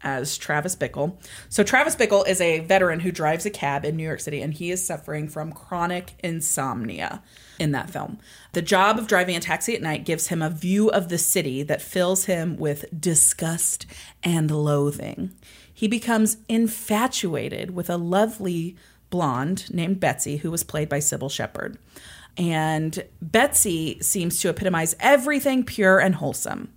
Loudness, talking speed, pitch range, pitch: -23 LUFS, 165 wpm, 155-195 Hz, 175 Hz